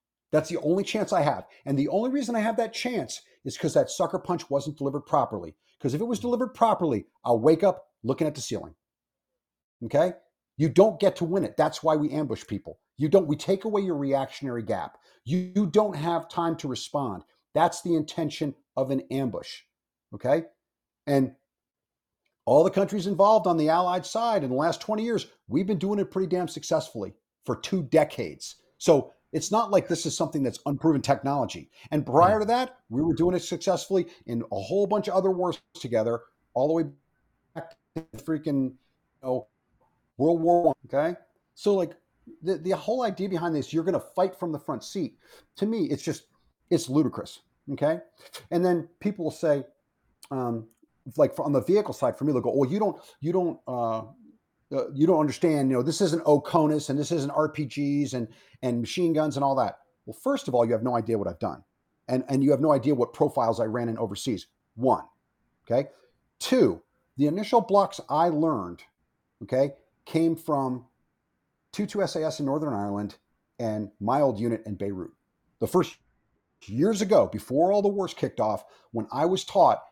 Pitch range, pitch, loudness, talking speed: 135-185 Hz, 155 Hz, -26 LUFS, 190 wpm